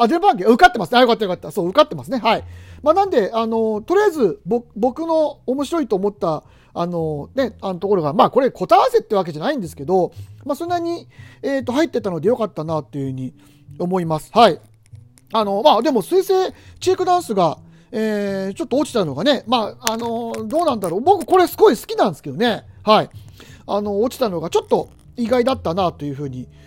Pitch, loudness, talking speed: 225 Hz, -19 LUFS, 400 characters per minute